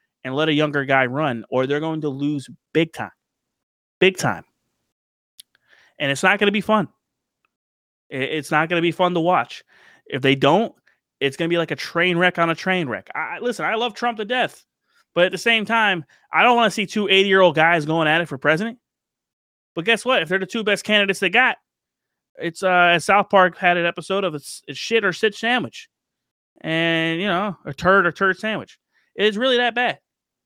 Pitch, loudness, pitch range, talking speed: 175 Hz, -19 LUFS, 155-205 Hz, 210 wpm